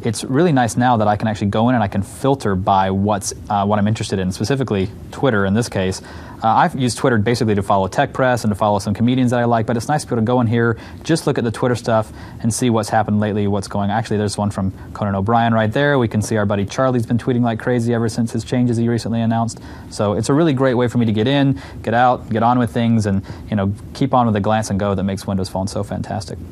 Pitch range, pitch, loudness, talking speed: 100-120 Hz, 110 Hz, -18 LUFS, 280 wpm